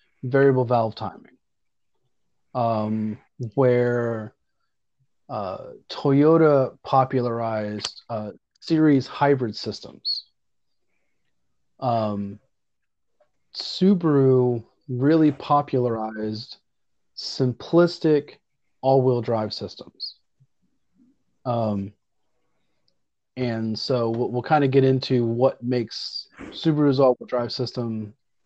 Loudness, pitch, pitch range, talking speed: -23 LUFS, 125 Hz, 110-135 Hz, 80 wpm